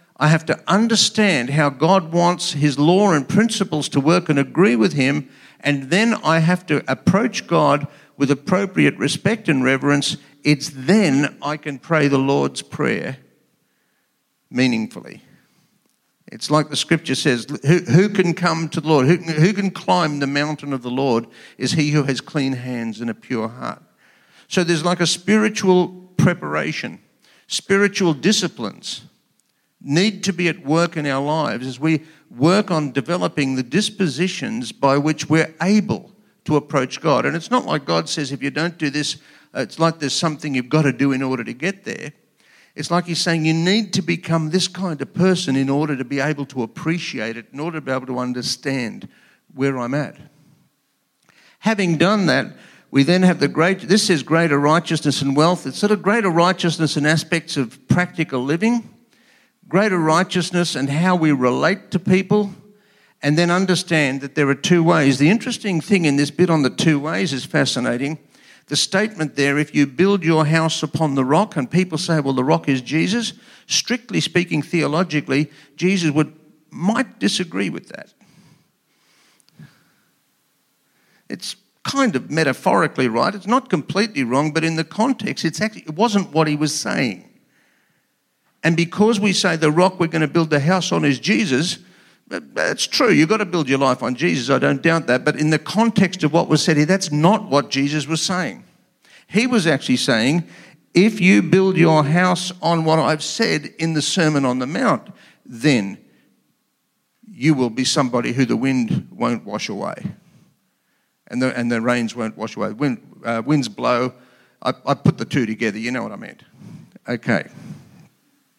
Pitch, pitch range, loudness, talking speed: 160 Hz, 140-185 Hz, -19 LUFS, 180 wpm